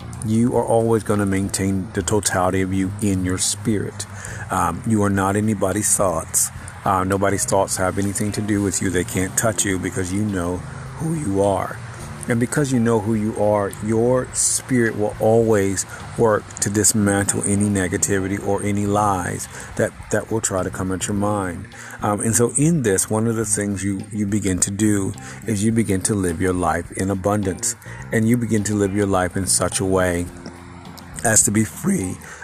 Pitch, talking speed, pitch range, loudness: 105 Hz, 190 wpm, 95-110 Hz, -20 LUFS